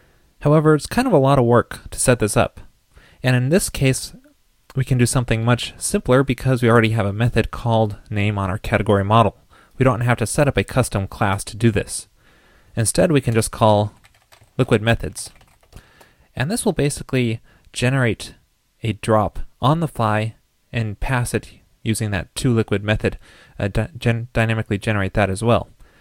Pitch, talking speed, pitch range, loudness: 115 Hz, 180 wpm, 105-130 Hz, -19 LUFS